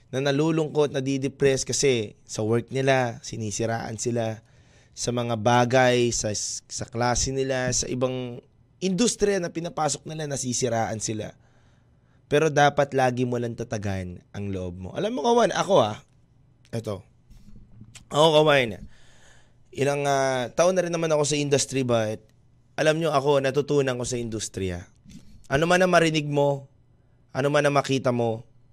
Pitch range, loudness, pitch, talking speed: 115-145 Hz, -24 LUFS, 125 Hz, 140 wpm